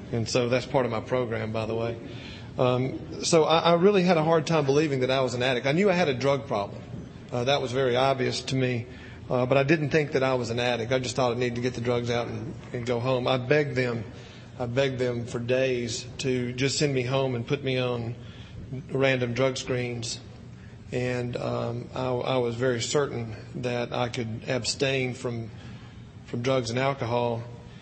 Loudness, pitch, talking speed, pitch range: -26 LUFS, 125 Hz, 215 wpm, 120-135 Hz